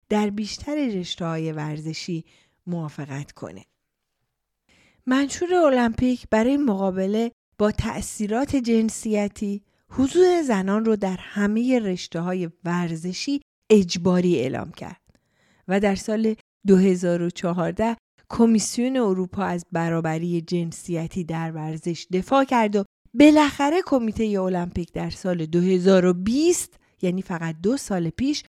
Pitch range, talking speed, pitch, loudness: 175-230 Hz, 105 wpm, 195 Hz, -23 LUFS